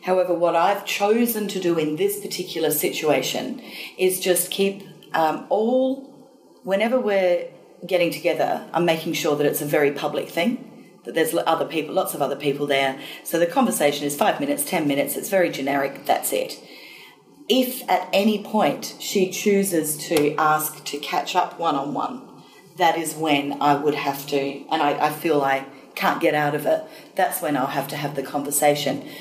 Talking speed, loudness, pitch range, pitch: 185 wpm, -22 LUFS, 145-195 Hz, 165 Hz